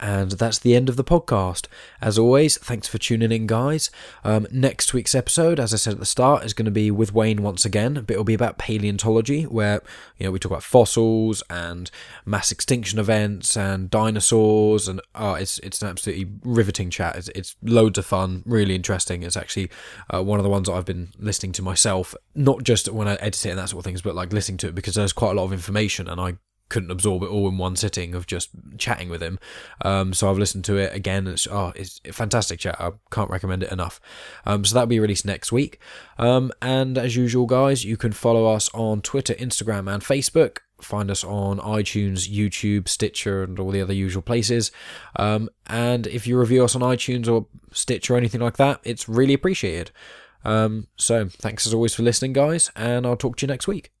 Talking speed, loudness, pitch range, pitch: 220 wpm, -22 LUFS, 95-120 Hz, 105 Hz